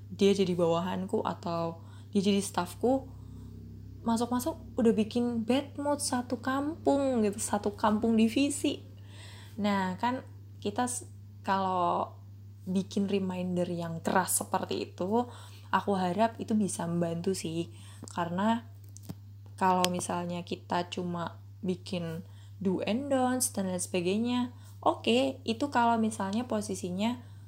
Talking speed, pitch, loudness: 110 wpm, 185 Hz, -31 LUFS